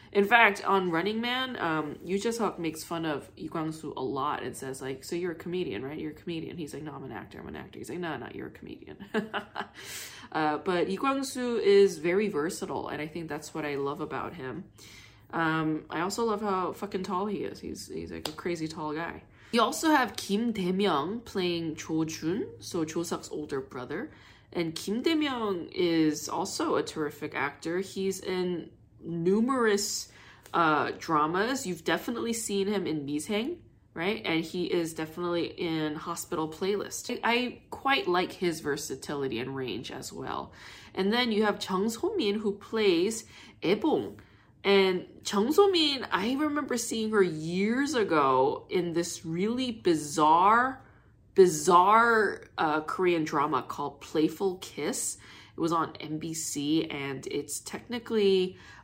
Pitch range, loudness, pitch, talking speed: 160-210 Hz, -29 LUFS, 180 Hz, 165 wpm